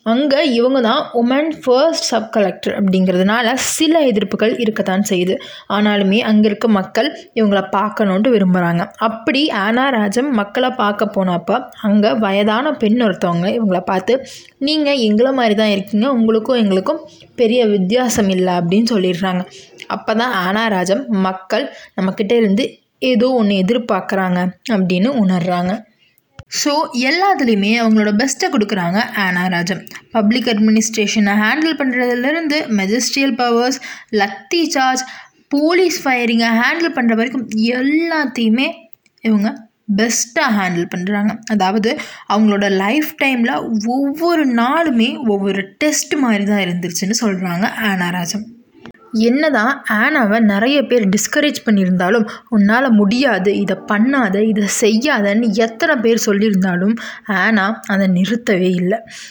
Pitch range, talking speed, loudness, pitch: 200-255 Hz, 110 wpm, -15 LUFS, 225 Hz